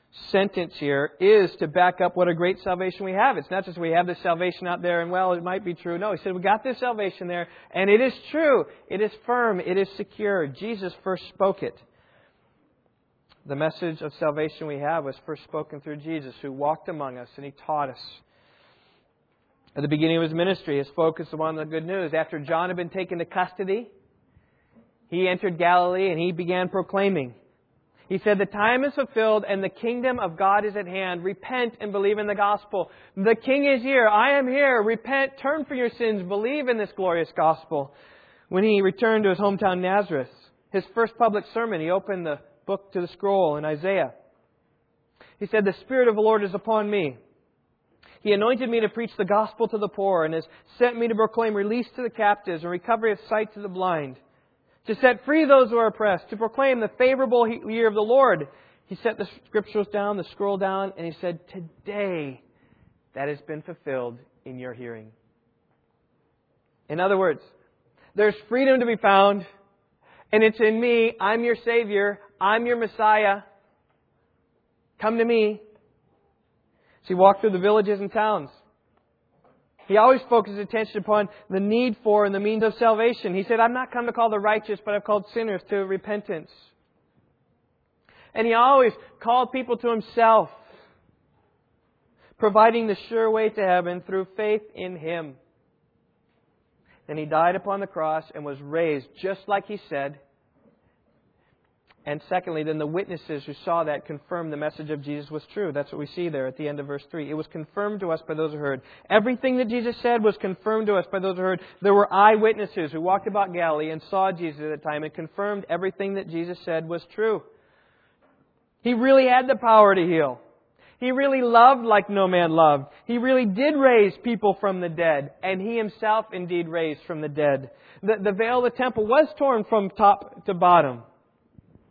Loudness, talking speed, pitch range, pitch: -23 LUFS, 190 wpm, 170-220 Hz, 195 Hz